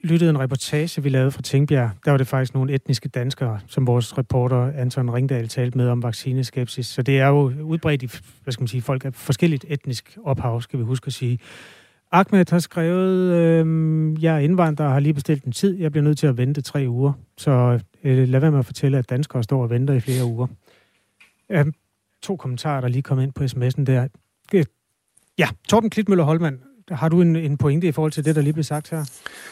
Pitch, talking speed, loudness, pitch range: 135 Hz, 220 wpm, -21 LUFS, 125-155 Hz